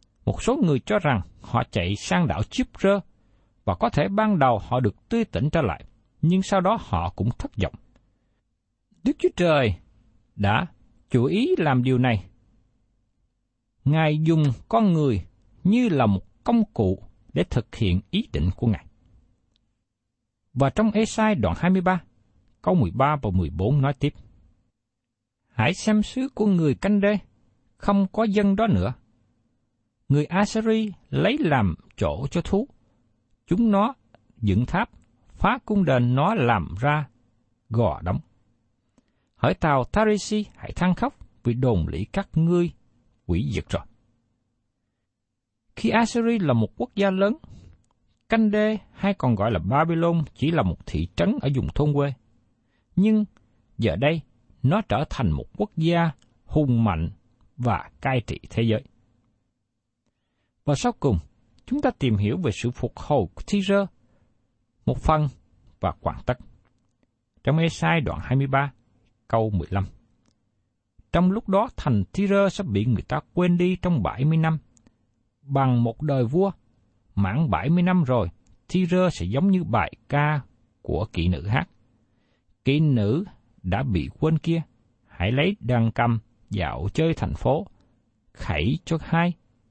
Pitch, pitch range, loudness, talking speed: 120 Hz, 110-165 Hz, -24 LUFS, 150 wpm